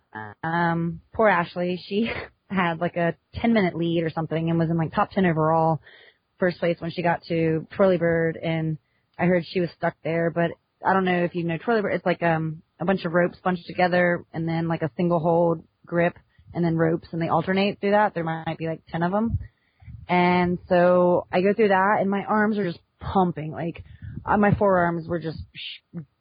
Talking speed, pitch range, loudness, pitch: 210 wpm, 165-180 Hz, -24 LUFS, 170 Hz